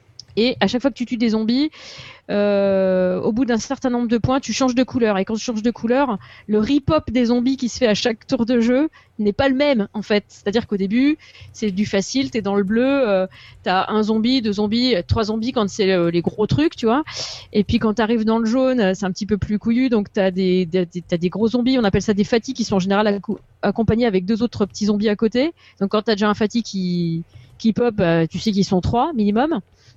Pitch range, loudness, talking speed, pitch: 200-245 Hz, -19 LUFS, 260 wpm, 220 Hz